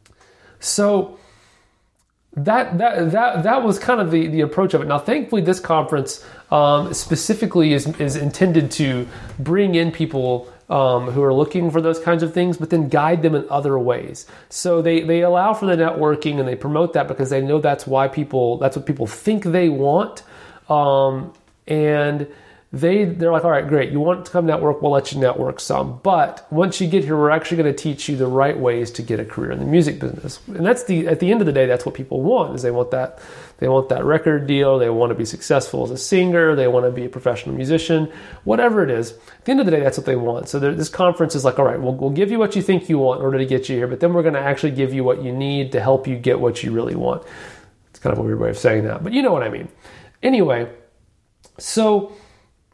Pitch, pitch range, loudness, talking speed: 150 Hz, 130-170 Hz, -18 LUFS, 240 wpm